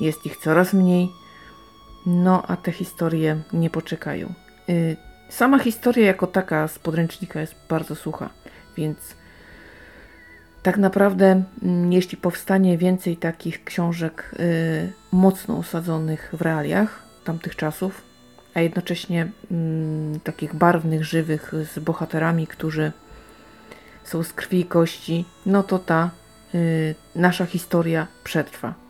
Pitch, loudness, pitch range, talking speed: 170 Hz, -22 LUFS, 155-185 Hz, 120 wpm